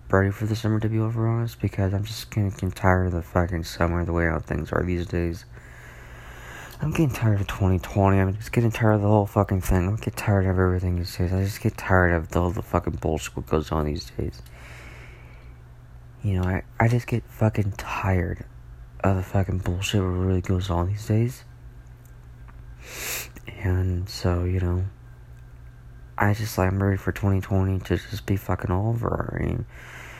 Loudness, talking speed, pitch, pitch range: -25 LUFS, 200 wpm, 95 Hz, 85-105 Hz